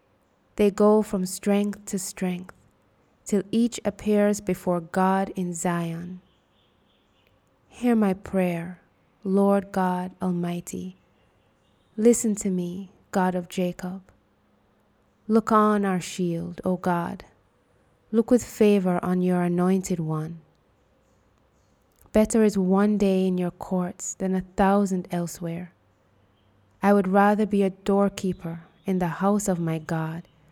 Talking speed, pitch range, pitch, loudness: 120 wpm, 175-200 Hz, 185 Hz, -24 LUFS